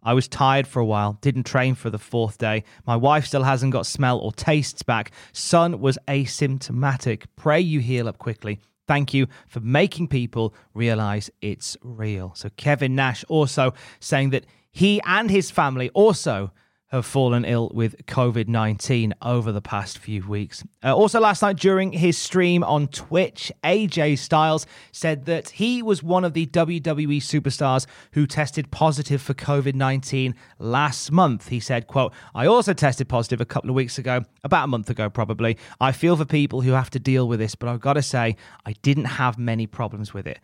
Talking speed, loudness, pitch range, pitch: 185 wpm, -22 LUFS, 115-150 Hz, 130 Hz